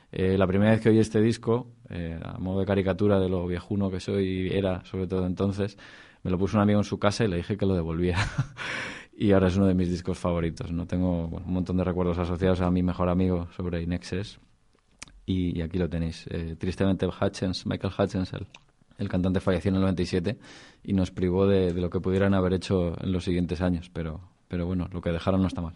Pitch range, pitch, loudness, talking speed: 90-100 Hz, 95 Hz, -27 LUFS, 230 wpm